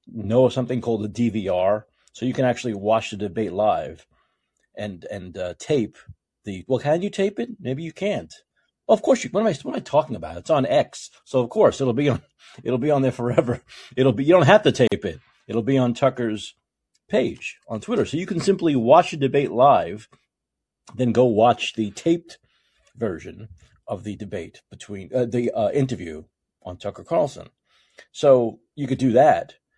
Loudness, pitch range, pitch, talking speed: -21 LUFS, 105-135 Hz, 120 Hz, 195 wpm